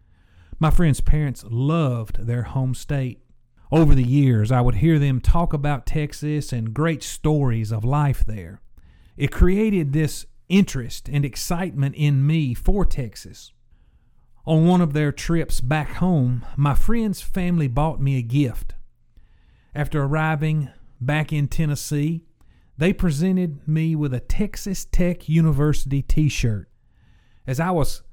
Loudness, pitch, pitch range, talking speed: -22 LUFS, 145 Hz, 125-160 Hz, 140 wpm